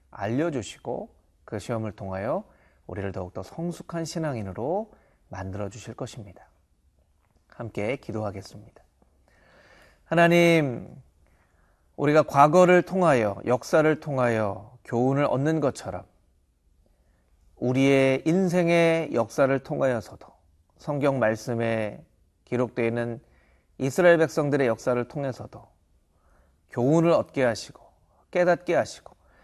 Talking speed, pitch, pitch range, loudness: 255 characters per minute, 115 Hz, 90-145 Hz, -24 LUFS